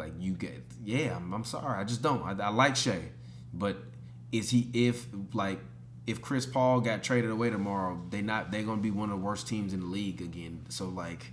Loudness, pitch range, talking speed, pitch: -32 LUFS, 85-115 Hz, 220 wpm, 100 Hz